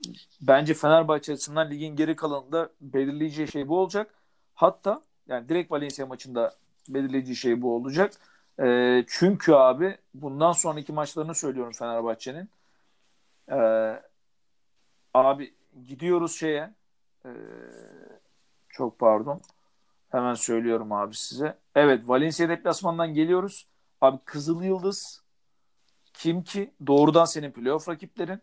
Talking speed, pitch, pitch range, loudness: 110 wpm, 150 Hz, 130-170 Hz, -25 LUFS